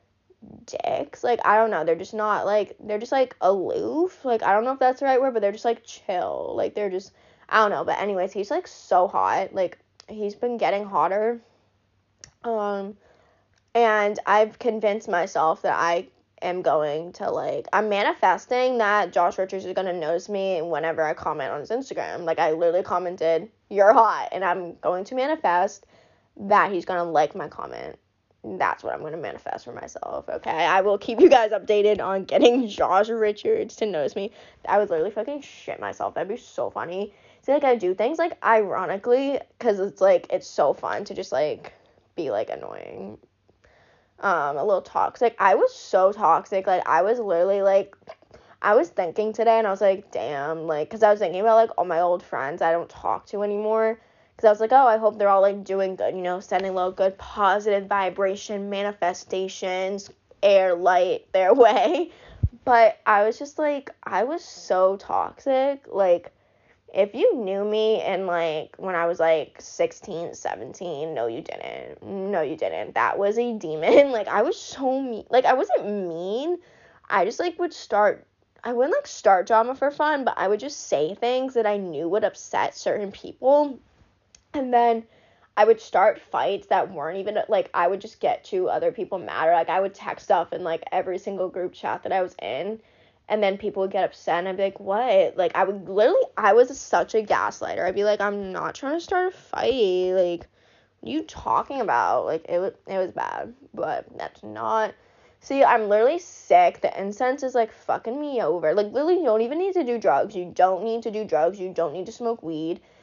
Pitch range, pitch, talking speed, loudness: 185-245 Hz, 205 Hz, 200 wpm, -23 LUFS